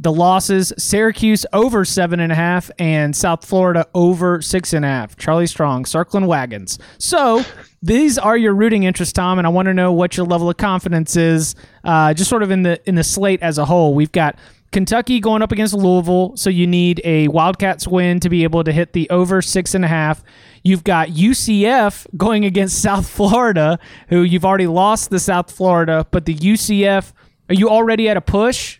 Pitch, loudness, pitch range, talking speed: 180 Hz, -15 LUFS, 165-200 Hz, 200 wpm